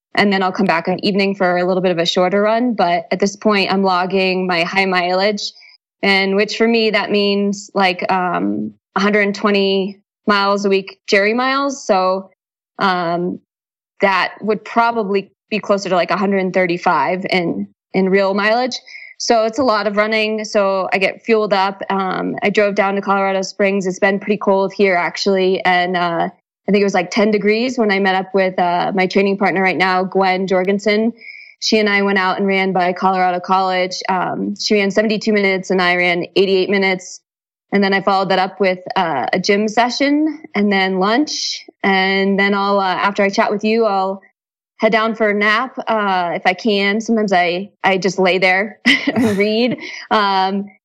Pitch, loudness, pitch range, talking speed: 195 Hz, -16 LUFS, 185-210 Hz, 190 wpm